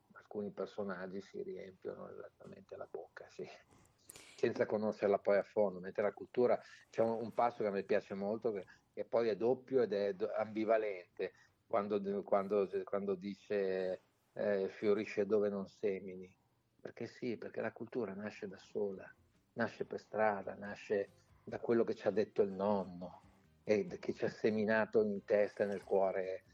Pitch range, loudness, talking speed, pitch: 95-105 Hz, -38 LUFS, 160 wpm, 100 Hz